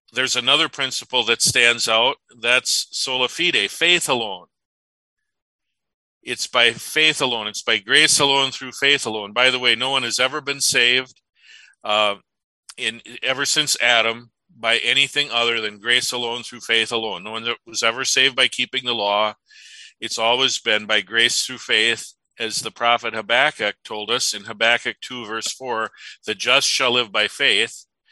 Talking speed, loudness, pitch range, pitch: 170 wpm, -18 LUFS, 115-135 Hz, 125 Hz